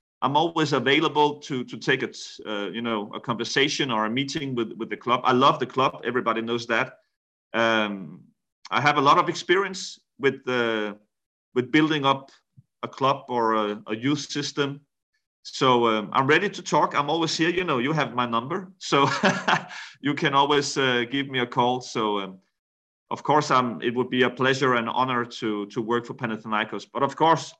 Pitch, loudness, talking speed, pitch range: 130 Hz, -24 LUFS, 195 wpm, 115-145 Hz